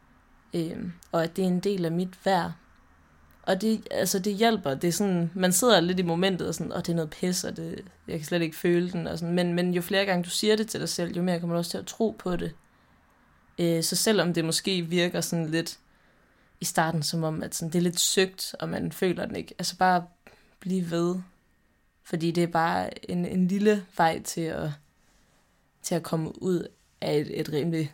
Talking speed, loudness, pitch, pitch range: 230 wpm, -27 LUFS, 175 Hz, 165-185 Hz